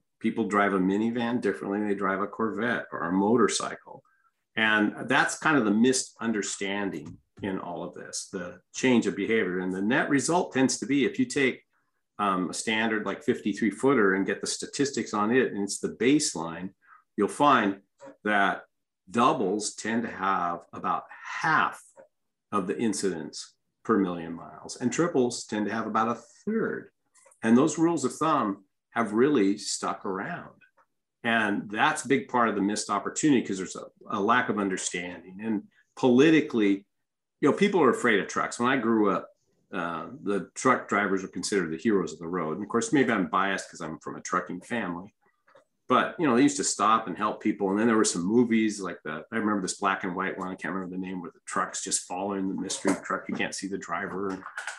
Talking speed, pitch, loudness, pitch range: 200 wpm, 105 Hz, -27 LUFS, 95-115 Hz